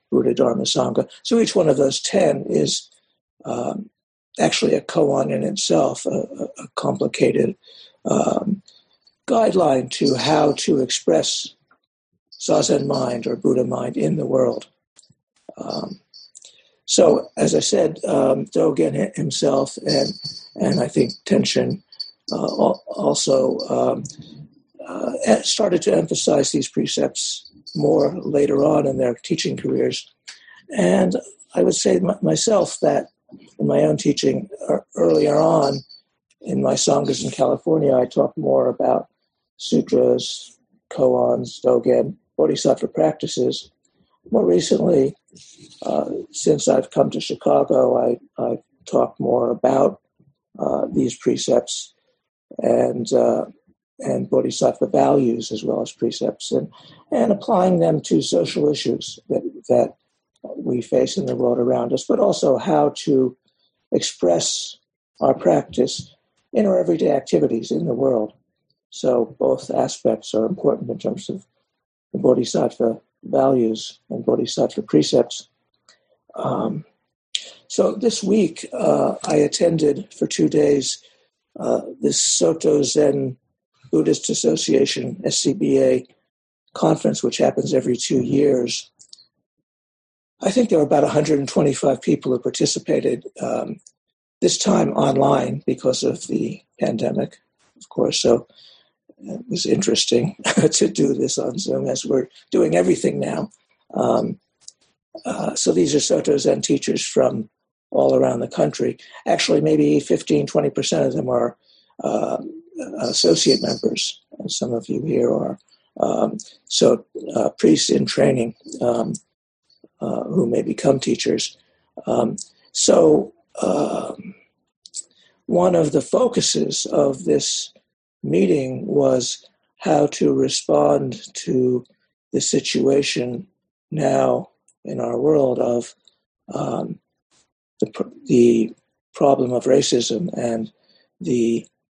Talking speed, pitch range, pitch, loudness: 120 wpm, 120-195 Hz, 140 Hz, -20 LUFS